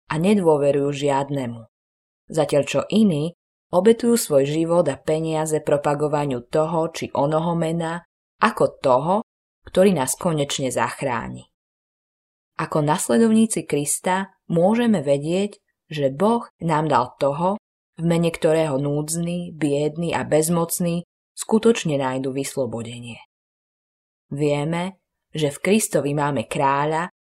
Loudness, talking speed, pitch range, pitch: -21 LUFS, 105 wpm, 140-175 Hz, 155 Hz